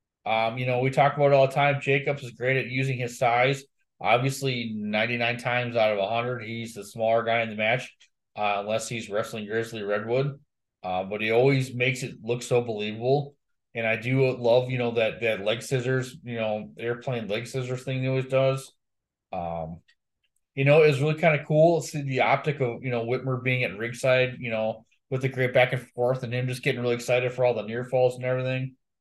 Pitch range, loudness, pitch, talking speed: 115-130 Hz, -25 LUFS, 125 Hz, 220 wpm